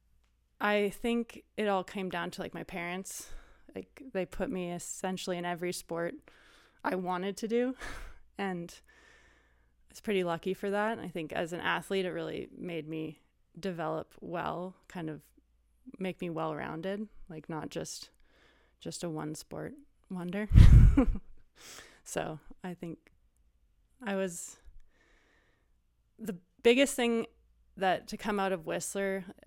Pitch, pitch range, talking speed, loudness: 185 Hz, 170-205 Hz, 140 wpm, -33 LUFS